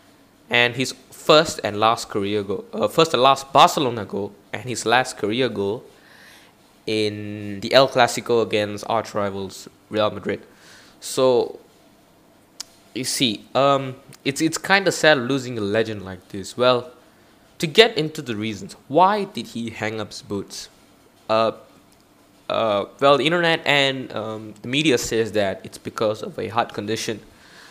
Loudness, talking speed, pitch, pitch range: -21 LUFS, 155 wpm, 115 Hz, 105-135 Hz